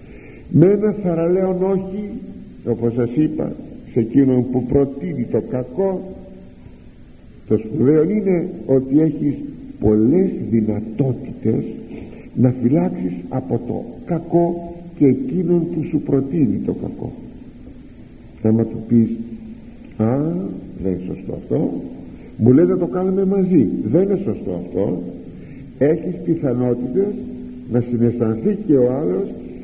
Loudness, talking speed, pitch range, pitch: -19 LUFS, 115 wpm, 120-185 Hz, 150 Hz